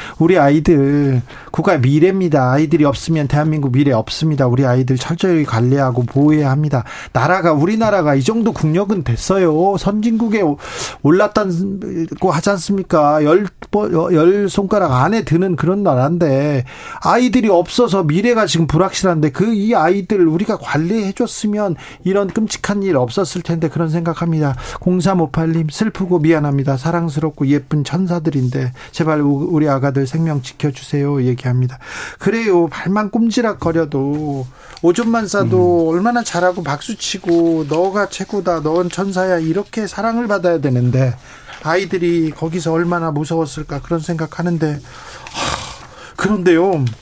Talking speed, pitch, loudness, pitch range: 330 characters per minute, 170 Hz, -16 LUFS, 145-195 Hz